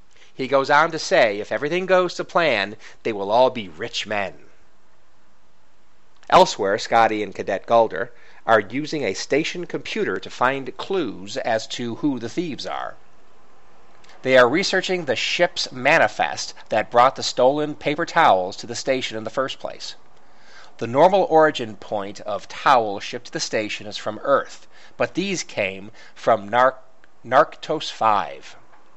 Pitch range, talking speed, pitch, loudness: 115-165 Hz, 155 wpm, 135 Hz, -21 LUFS